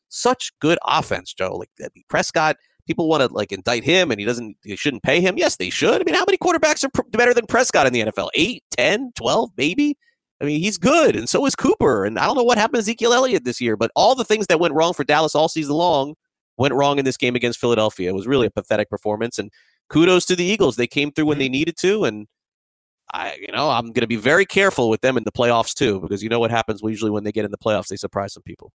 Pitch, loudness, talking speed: 145 Hz, -19 LUFS, 265 wpm